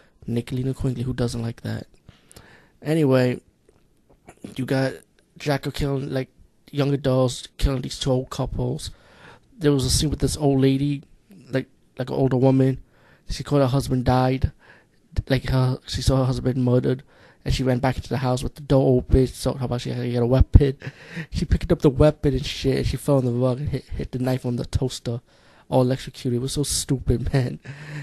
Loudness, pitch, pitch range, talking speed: -23 LUFS, 130 Hz, 125-140 Hz, 195 wpm